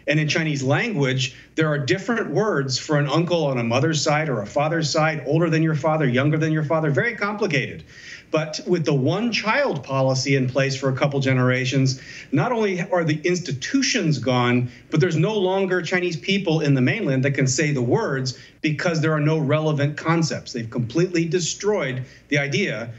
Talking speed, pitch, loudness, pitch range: 190 wpm, 155 Hz, -21 LUFS, 135-170 Hz